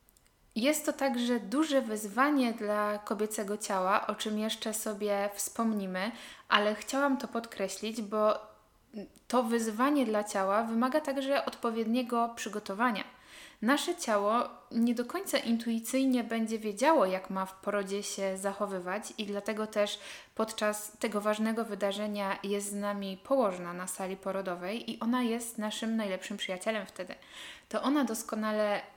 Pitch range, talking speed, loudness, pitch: 205-240 Hz, 135 wpm, -32 LUFS, 215 Hz